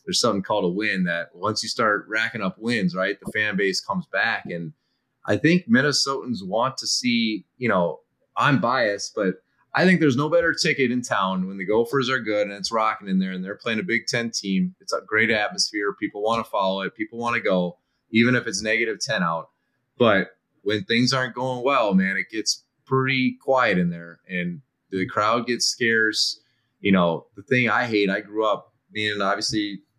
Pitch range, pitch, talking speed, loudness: 95-130 Hz, 110 Hz, 205 wpm, -23 LUFS